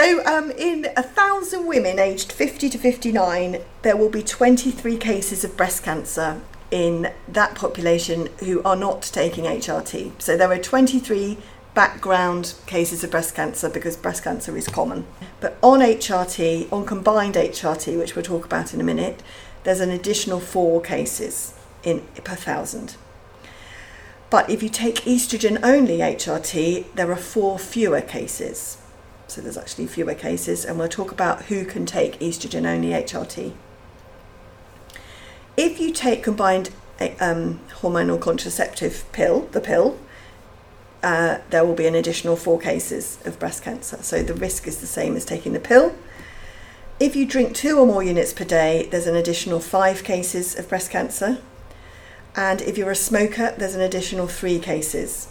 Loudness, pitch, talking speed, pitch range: -21 LUFS, 185 Hz, 155 wpm, 165-215 Hz